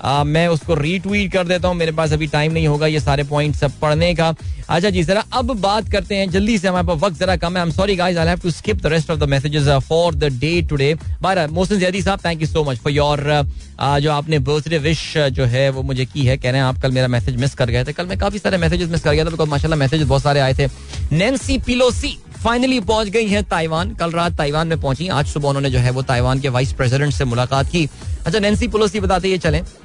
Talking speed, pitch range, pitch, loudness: 245 wpm, 140-180 Hz, 155 Hz, -17 LUFS